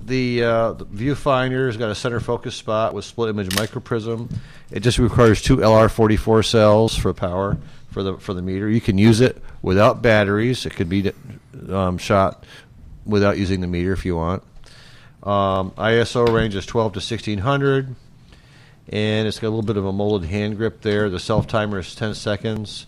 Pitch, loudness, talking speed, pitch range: 110 Hz, -20 LUFS, 185 wpm, 100-120 Hz